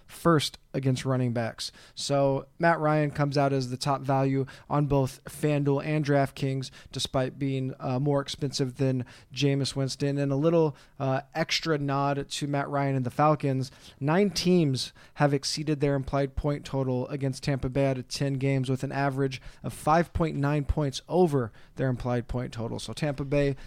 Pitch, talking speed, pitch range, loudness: 140 Hz, 165 wpm, 130-145 Hz, -28 LUFS